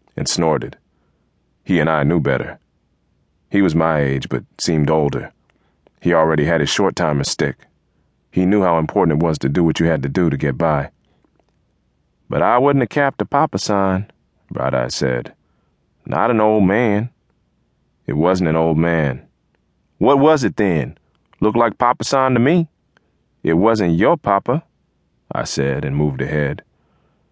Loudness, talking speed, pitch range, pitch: -17 LUFS, 165 wpm, 80-120 Hz, 95 Hz